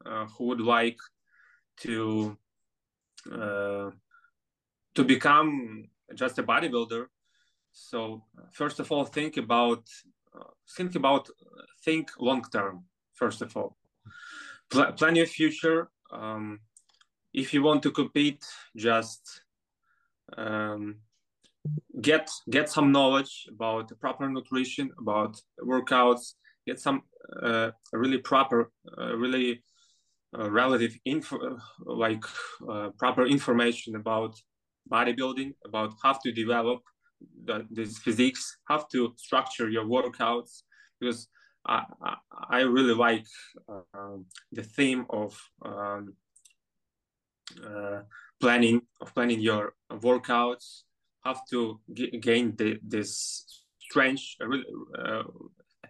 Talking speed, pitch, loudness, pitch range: 115 wpm, 120 Hz, -28 LUFS, 110-135 Hz